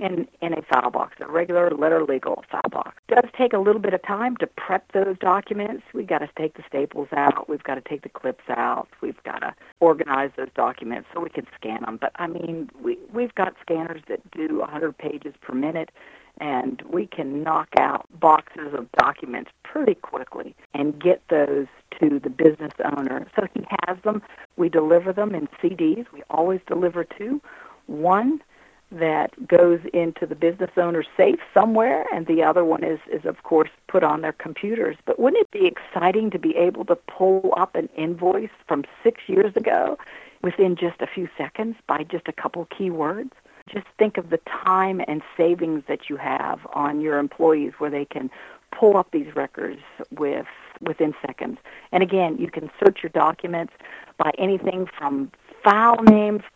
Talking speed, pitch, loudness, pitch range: 185 wpm, 175 Hz, -22 LUFS, 155-210 Hz